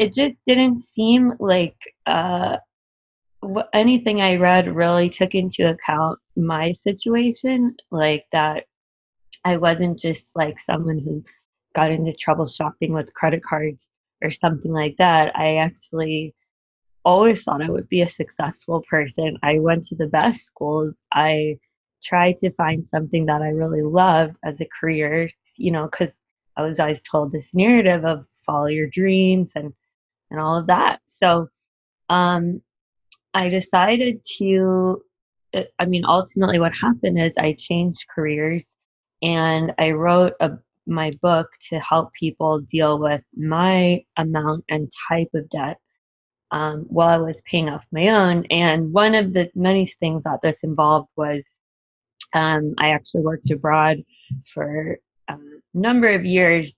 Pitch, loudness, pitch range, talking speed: 165 Hz, -20 LUFS, 155-180 Hz, 145 wpm